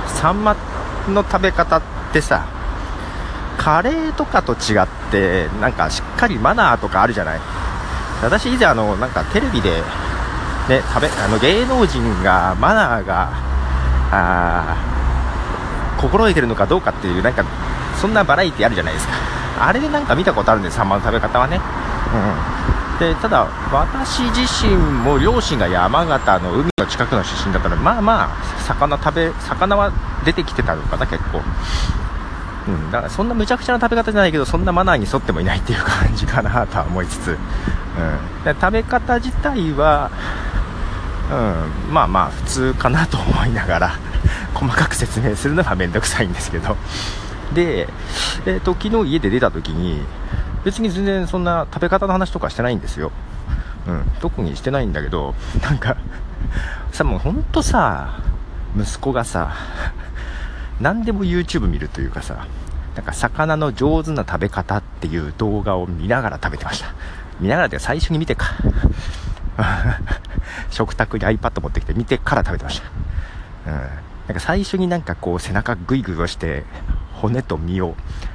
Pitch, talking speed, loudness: 95 Hz, 325 characters per minute, -19 LUFS